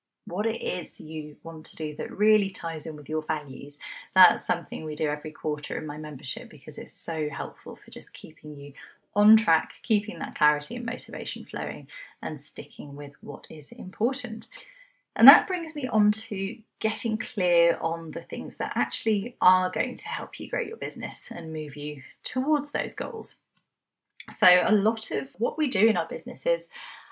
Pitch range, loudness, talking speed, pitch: 155-225 Hz, -27 LUFS, 180 wpm, 185 Hz